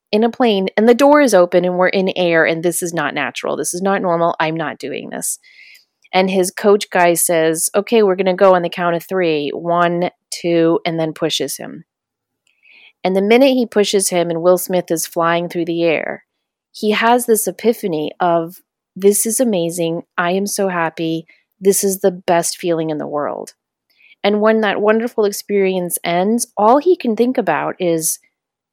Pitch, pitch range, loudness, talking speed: 185 Hz, 170-210 Hz, -16 LUFS, 190 wpm